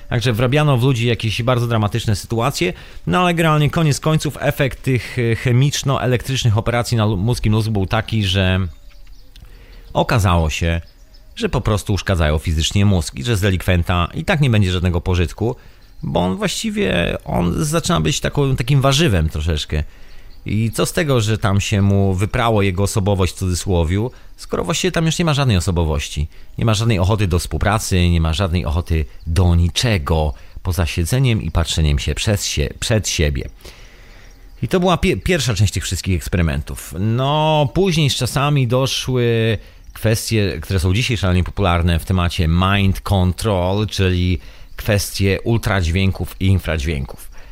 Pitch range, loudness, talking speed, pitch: 90-125 Hz, -18 LUFS, 155 wpm, 100 Hz